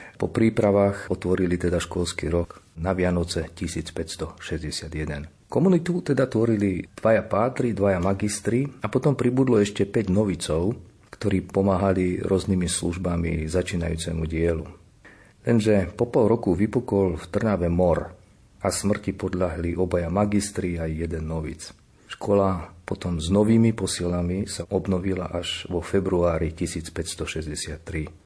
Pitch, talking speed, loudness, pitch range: 90 Hz, 115 wpm, -24 LUFS, 85-100 Hz